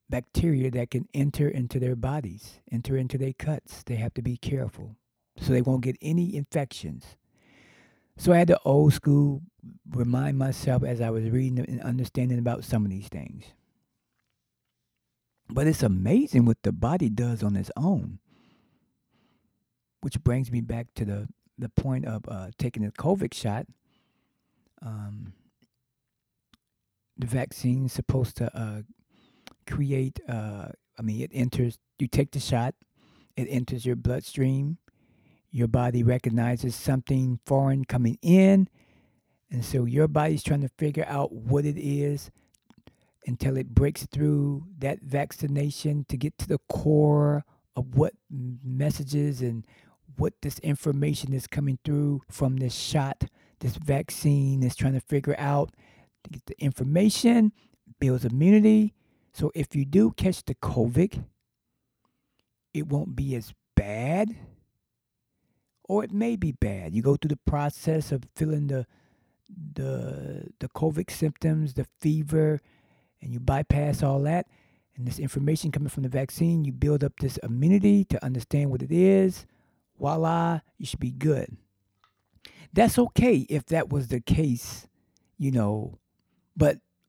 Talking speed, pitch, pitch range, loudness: 145 wpm, 135 Hz, 120-150 Hz, -26 LUFS